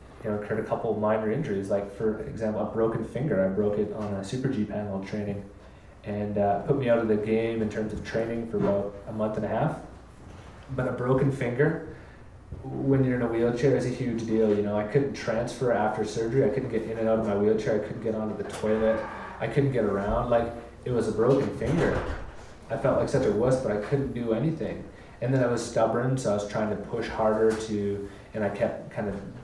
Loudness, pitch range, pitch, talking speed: -27 LUFS, 105-120 Hz, 110 Hz, 235 wpm